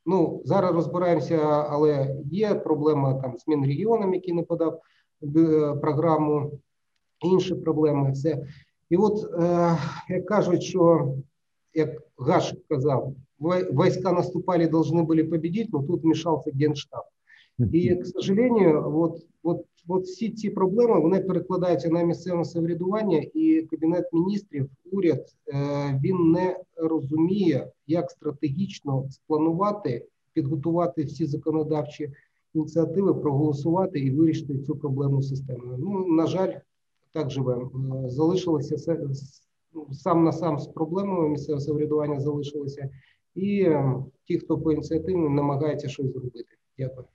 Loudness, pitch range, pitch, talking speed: -25 LUFS, 145-175 Hz, 160 Hz, 115 wpm